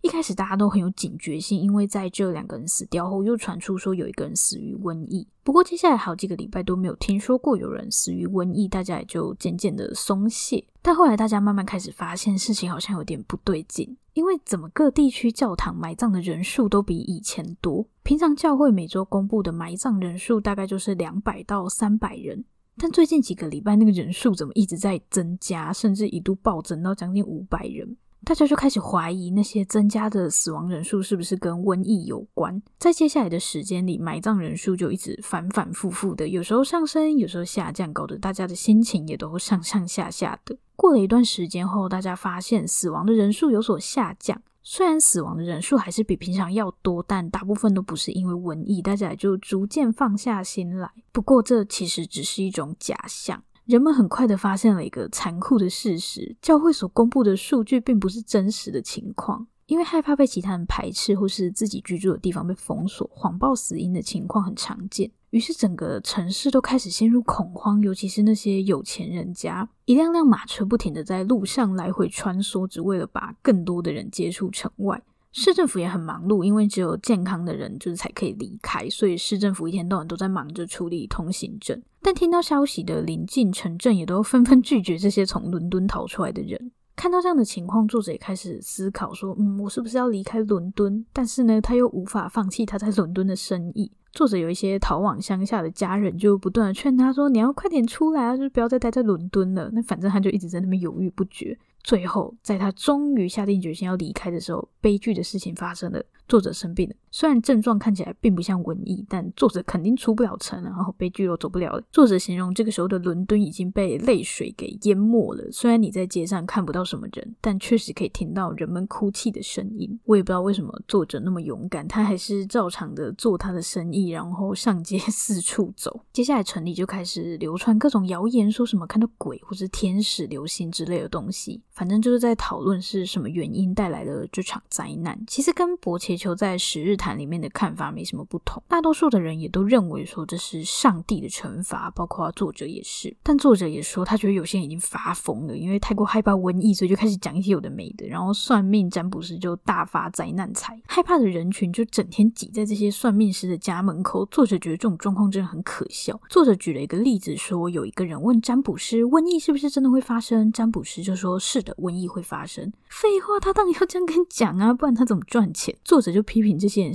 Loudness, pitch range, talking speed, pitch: -23 LUFS, 185-230 Hz, 335 characters per minute, 200 Hz